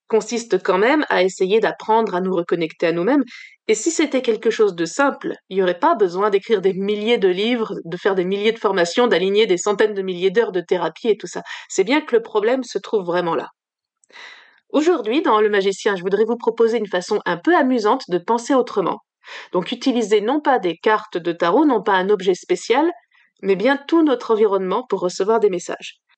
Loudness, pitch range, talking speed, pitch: -19 LUFS, 195-290 Hz, 210 wpm, 225 Hz